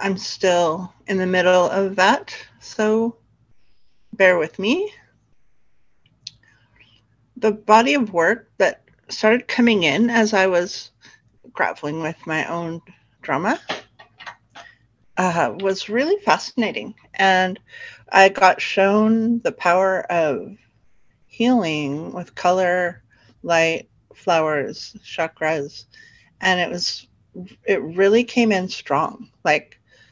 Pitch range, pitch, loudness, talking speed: 165-215 Hz, 185 Hz, -19 LUFS, 105 wpm